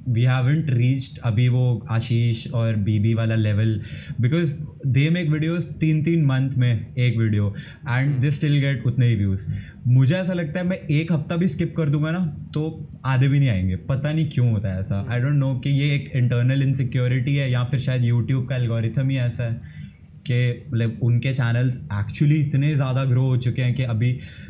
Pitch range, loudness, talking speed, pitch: 120-145 Hz, -22 LUFS, 200 wpm, 130 Hz